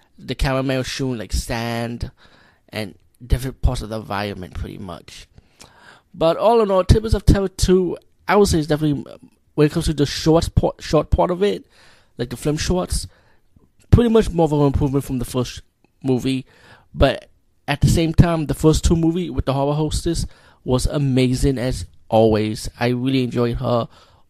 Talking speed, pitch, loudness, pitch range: 180 wpm, 130 Hz, -20 LUFS, 115-155 Hz